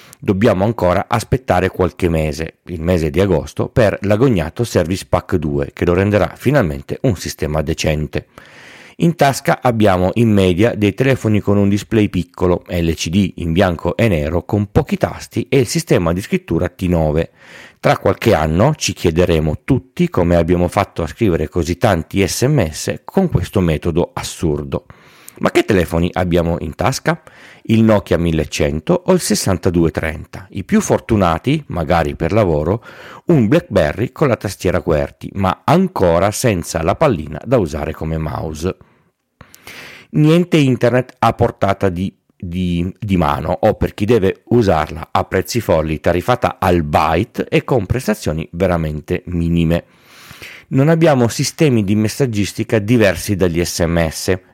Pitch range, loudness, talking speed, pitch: 85-115 Hz, -16 LUFS, 140 wpm, 95 Hz